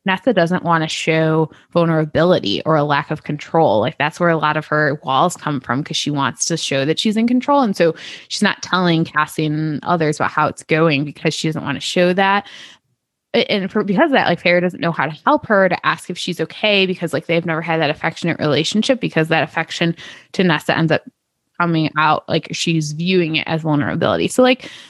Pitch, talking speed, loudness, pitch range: 160 Hz, 220 wpm, -17 LUFS, 155-180 Hz